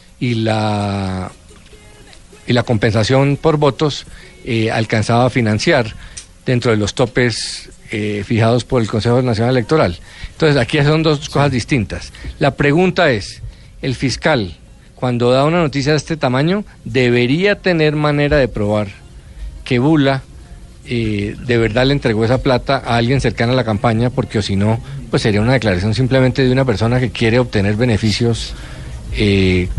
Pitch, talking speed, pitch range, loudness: 120 Hz, 155 wpm, 105-135 Hz, -15 LUFS